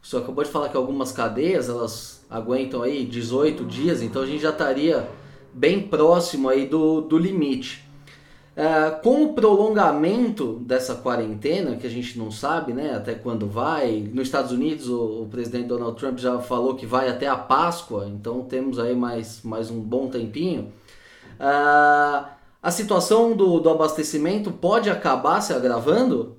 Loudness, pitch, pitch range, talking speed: -22 LUFS, 130 Hz, 120-155 Hz, 165 wpm